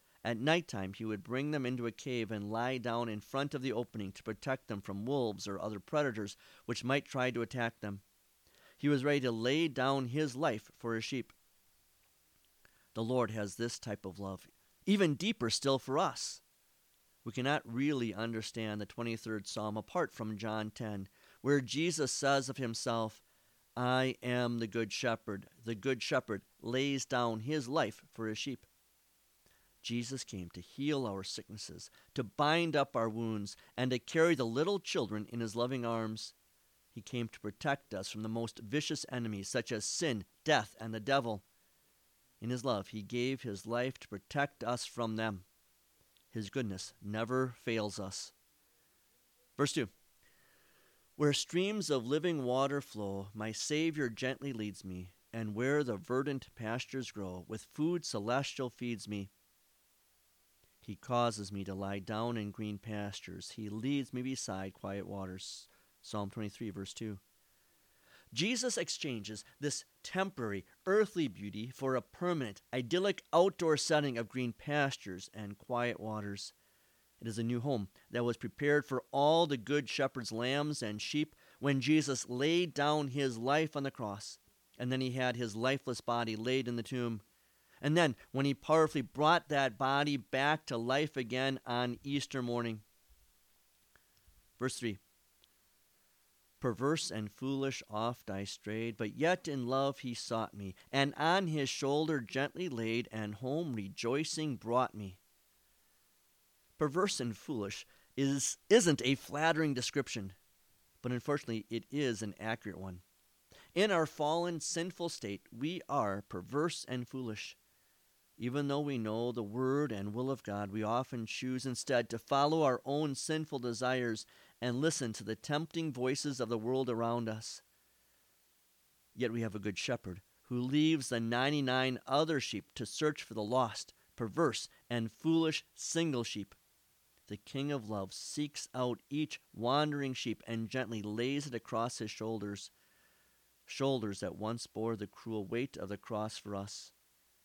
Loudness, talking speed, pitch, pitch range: -36 LUFS, 155 wpm, 120 Hz, 110-140 Hz